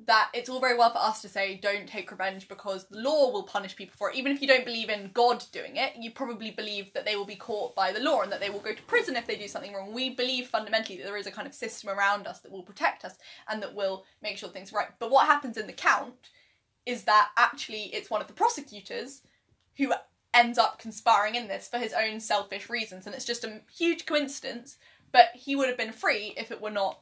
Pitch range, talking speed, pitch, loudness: 200-250 Hz, 260 wpm, 225 Hz, -28 LUFS